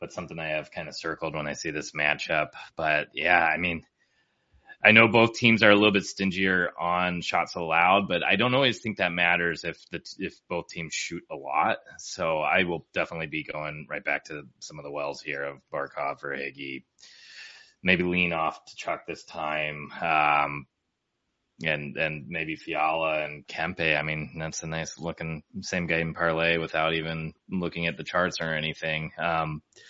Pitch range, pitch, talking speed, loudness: 75-90 Hz, 80 Hz, 185 wpm, -26 LUFS